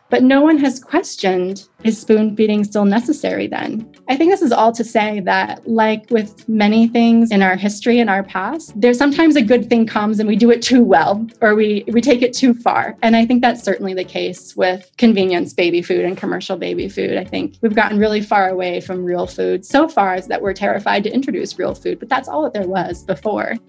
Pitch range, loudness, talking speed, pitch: 190-245 Hz, -16 LUFS, 230 wpm, 215 Hz